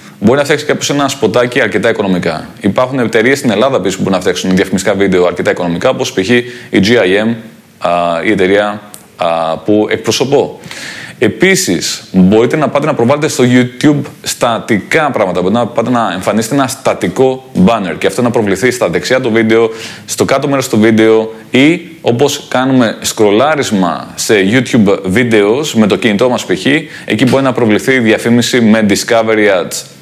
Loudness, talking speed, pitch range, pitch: -11 LUFS, 160 wpm, 105-130 Hz, 115 Hz